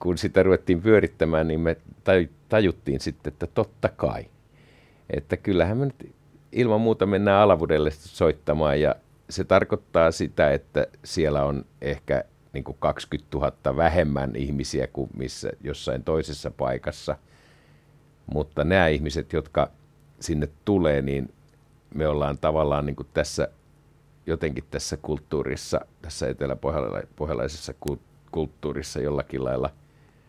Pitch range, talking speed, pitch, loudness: 70-90 Hz, 110 wpm, 80 Hz, -25 LUFS